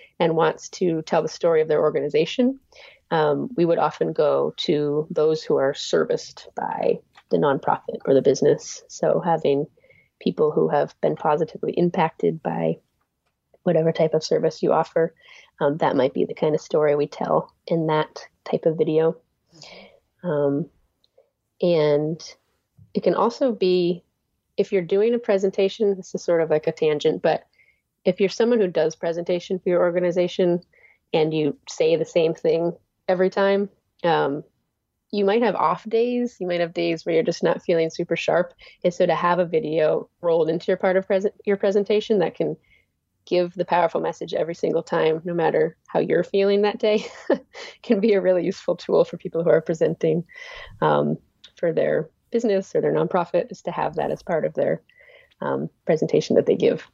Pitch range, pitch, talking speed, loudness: 165-245 Hz, 185 Hz, 180 wpm, -22 LUFS